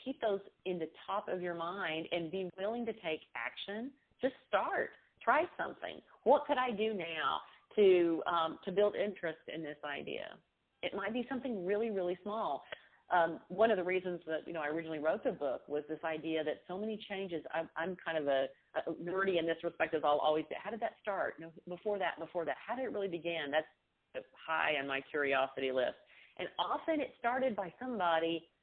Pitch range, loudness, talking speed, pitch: 160-220 Hz, -36 LUFS, 205 wpm, 180 Hz